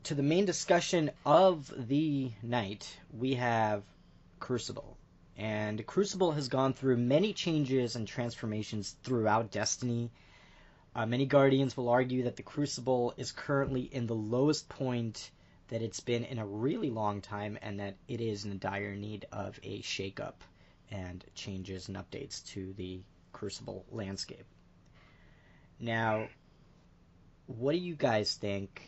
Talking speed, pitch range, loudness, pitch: 145 wpm, 100-130 Hz, -33 LUFS, 115 Hz